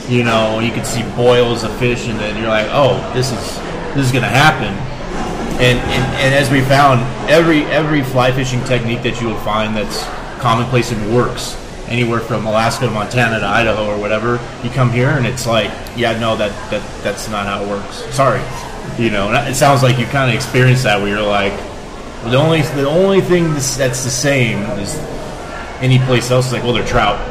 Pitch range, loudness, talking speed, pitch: 110-130 Hz, -15 LUFS, 205 wpm, 120 Hz